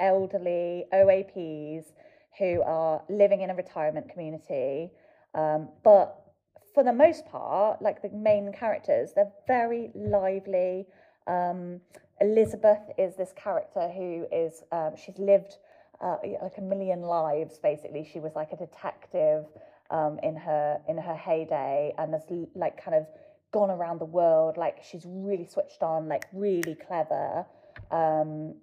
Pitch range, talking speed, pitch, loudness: 160-200 Hz, 140 wpm, 185 Hz, -28 LUFS